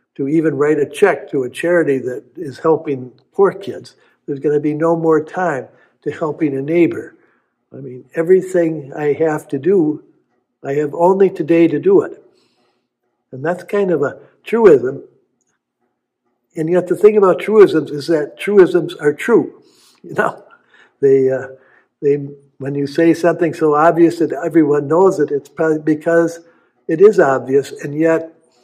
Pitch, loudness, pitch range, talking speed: 160 Hz, -15 LUFS, 145-175 Hz, 165 wpm